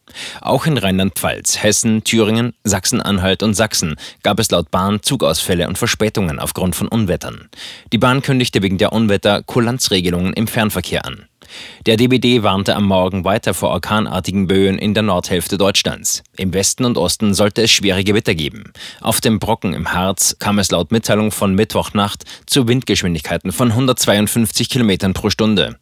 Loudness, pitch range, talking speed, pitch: -15 LUFS, 95-115 Hz, 160 wpm, 105 Hz